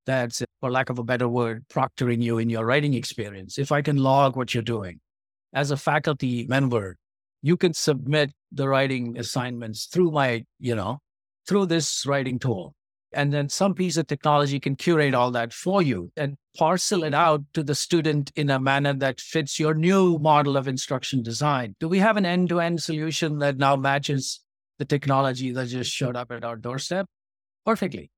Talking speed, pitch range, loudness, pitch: 190 wpm, 125-155 Hz, -24 LUFS, 140 Hz